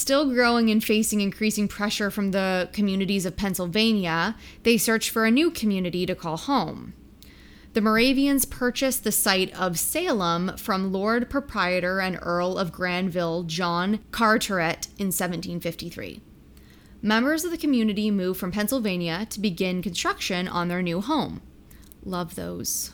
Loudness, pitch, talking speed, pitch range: -24 LUFS, 200 Hz, 140 wpm, 180-225 Hz